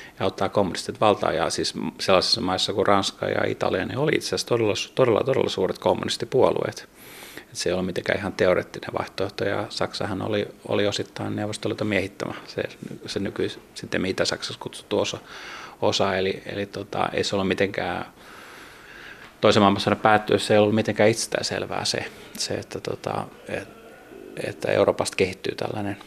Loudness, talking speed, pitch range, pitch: -24 LUFS, 150 wpm, 100-110 Hz, 105 Hz